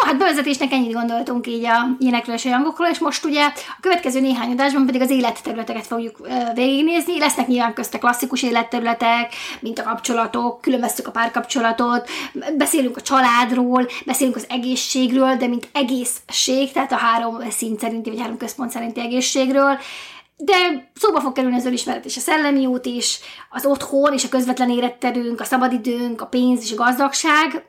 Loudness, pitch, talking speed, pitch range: -19 LUFS, 250 Hz, 170 wpm, 240-275 Hz